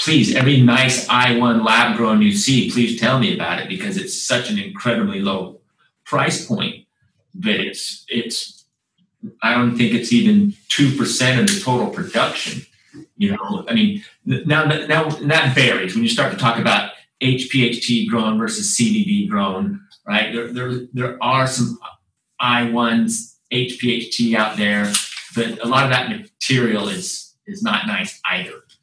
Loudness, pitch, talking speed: -18 LUFS, 130 Hz, 180 wpm